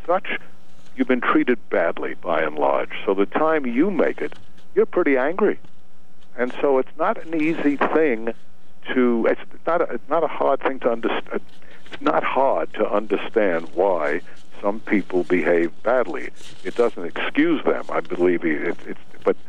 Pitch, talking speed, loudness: 145 Hz, 165 wpm, -22 LUFS